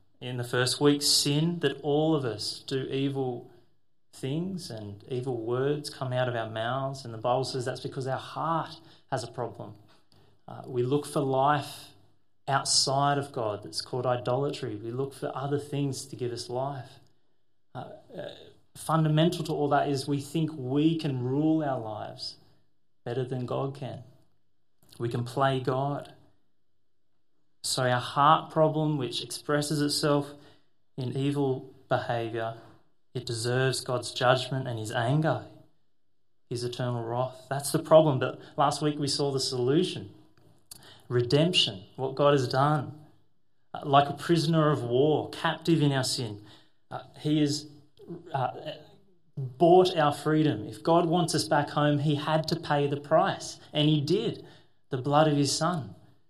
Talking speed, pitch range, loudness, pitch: 155 wpm, 125-150 Hz, -28 LUFS, 140 Hz